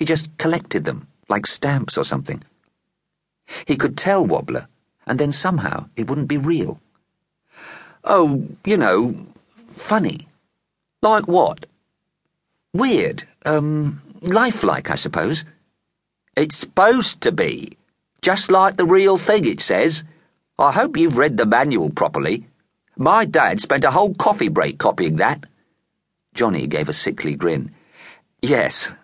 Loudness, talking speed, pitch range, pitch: -18 LUFS, 130 wpm, 150-210 Hz, 170 Hz